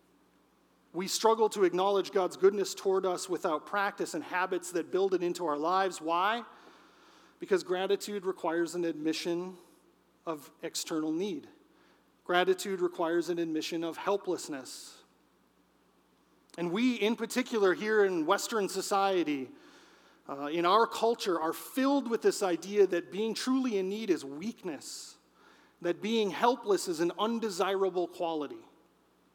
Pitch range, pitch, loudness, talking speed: 175-225 Hz, 190 Hz, -31 LUFS, 130 wpm